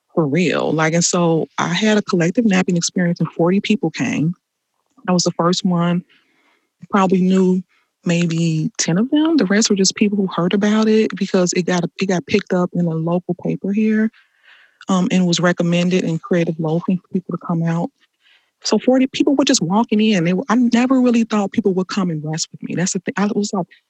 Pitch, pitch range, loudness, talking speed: 190 Hz, 175-215 Hz, -17 LUFS, 215 wpm